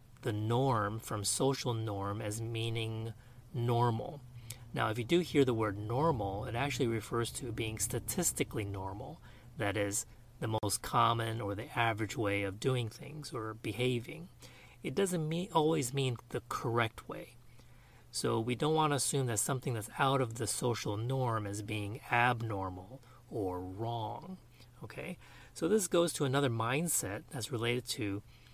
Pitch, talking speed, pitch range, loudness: 120 Hz, 155 wpm, 110-135 Hz, -34 LUFS